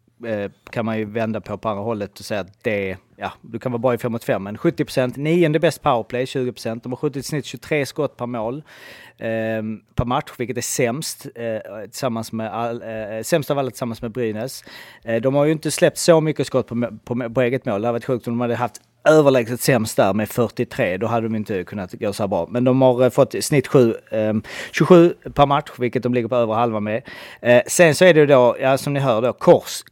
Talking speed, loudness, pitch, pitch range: 235 wpm, -20 LUFS, 120 Hz, 110-140 Hz